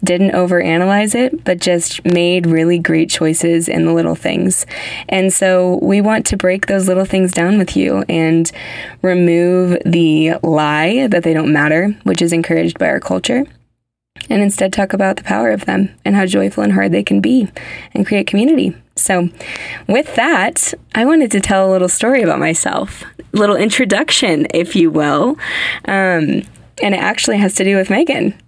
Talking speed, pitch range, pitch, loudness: 180 wpm, 165-200 Hz, 180 Hz, -13 LUFS